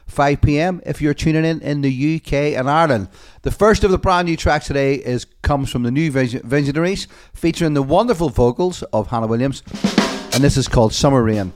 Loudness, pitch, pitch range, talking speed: -17 LUFS, 145 Hz, 125-165 Hz, 195 wpm